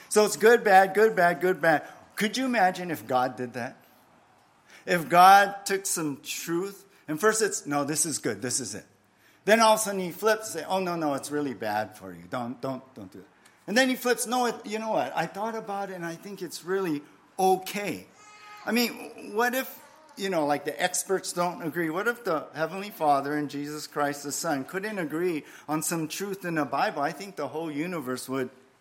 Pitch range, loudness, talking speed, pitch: 145-205 Hz, -26 LUFS, 220 wpm, 175 Hz